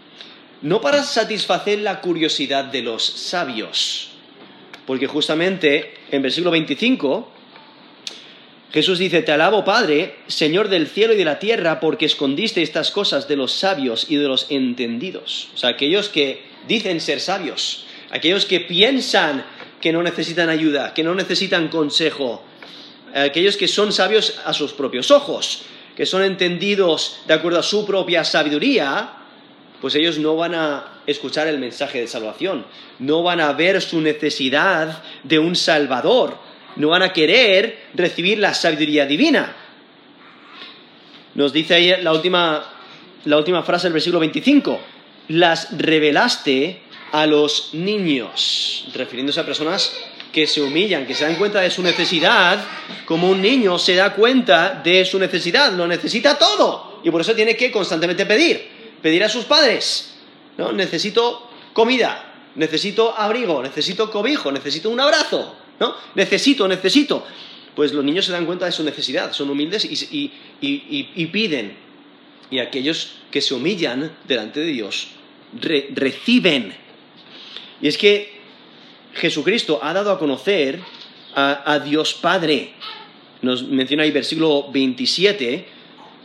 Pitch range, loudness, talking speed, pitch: 150-205 Hz, -18 LUFS, 145 wpm, 170 Hz